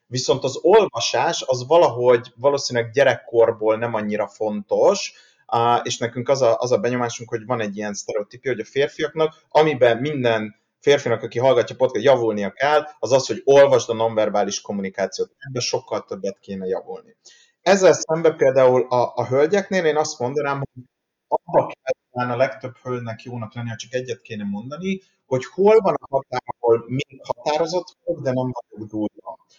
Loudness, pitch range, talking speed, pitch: -20 LUFS, 115-150 Hz, 160 wpm, 125 Hz